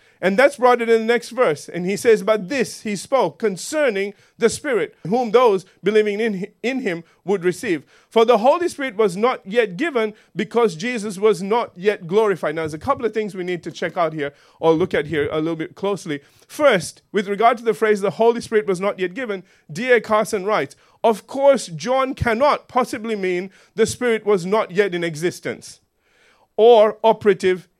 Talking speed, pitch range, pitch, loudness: 195 wpm, 185-235 Hz, 215 Hz, -19 LUFS